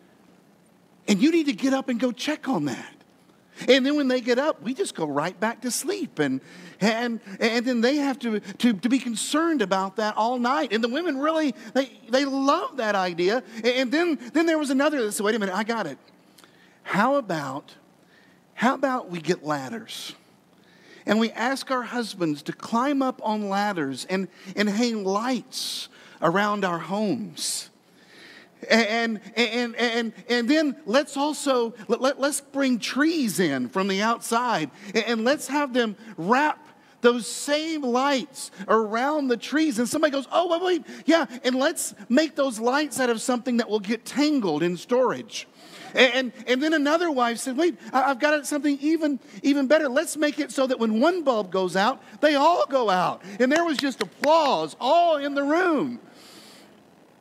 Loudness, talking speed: -24 LUFS, 180 wpm